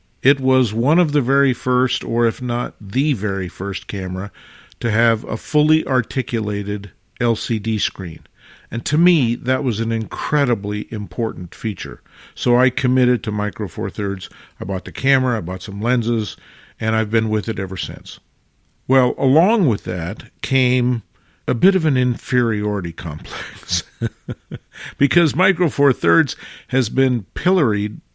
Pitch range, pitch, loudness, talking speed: 105-130 Hz, 115 Hz, -19 LUFS, 150 wpm